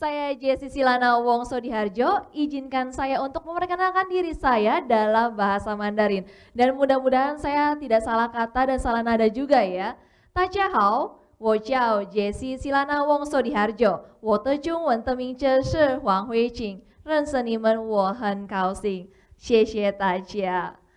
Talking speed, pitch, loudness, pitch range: 150 wpm, 245 Hz, -23 LUFS, 215-275 Hz